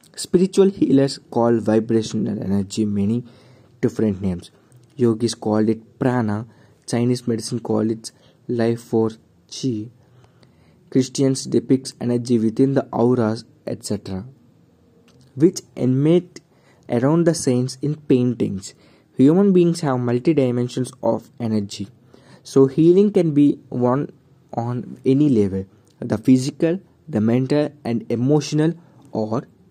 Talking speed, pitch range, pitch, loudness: 110 wpm, 115-140 Hz, 125 Hz, -20 LUFS